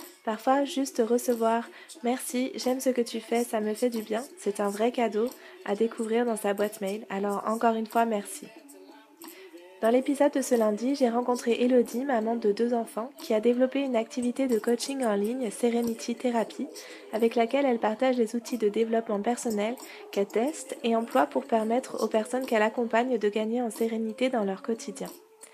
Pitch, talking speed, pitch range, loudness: 235 Hz, 185 wpm, 220-255 Hz, -28 LUFS